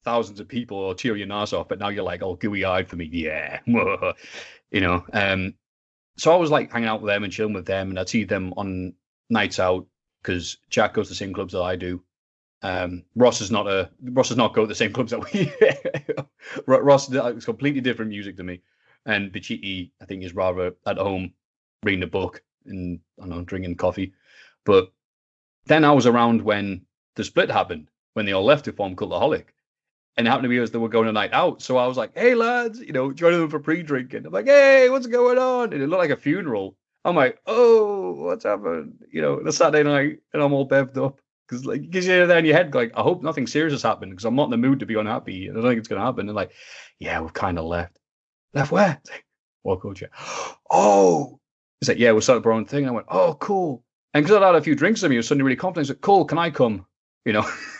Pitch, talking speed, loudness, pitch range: 115 Hz, 250 wpm, -21 LUFS, 95-145 Hz